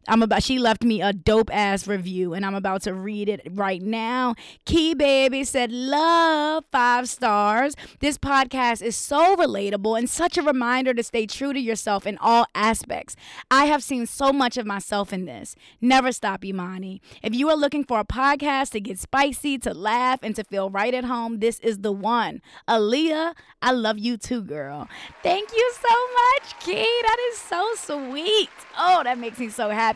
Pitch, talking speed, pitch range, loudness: 245 Hz, 190 wpm, 215-285 Hz, -22 LUFS